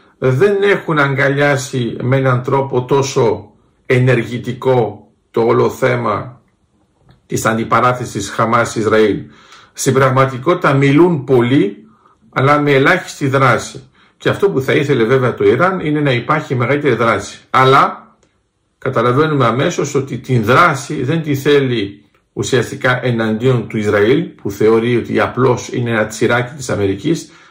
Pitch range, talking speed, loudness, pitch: 120-145 Hz, 125 wpm, -14 LUFS, 130 Hz